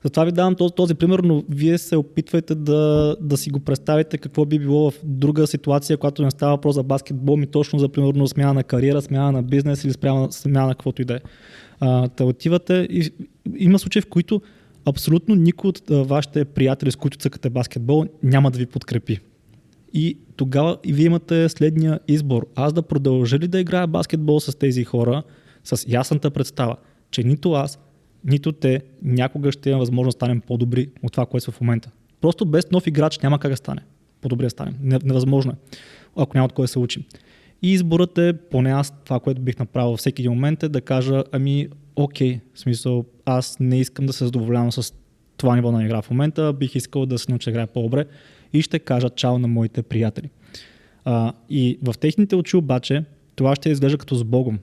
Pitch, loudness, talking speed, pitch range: 140 Hz, -20 LUFS, 200 wpm, 125-155 Hz